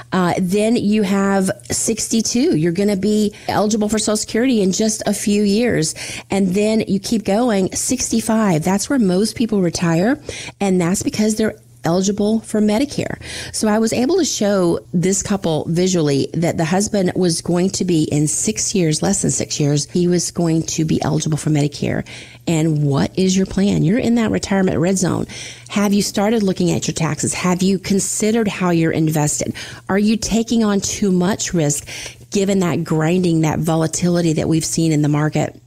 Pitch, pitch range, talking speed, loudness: 185 Hz, 160-210 Hz, 185 wpm, -17 LUFS